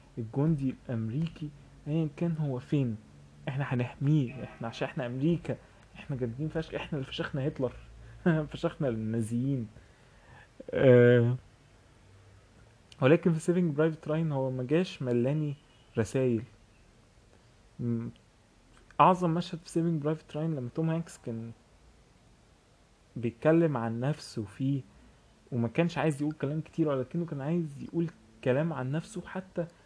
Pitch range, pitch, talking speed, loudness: 115-160 Hz, 135 Hz, 120 wpm, -30 LUFS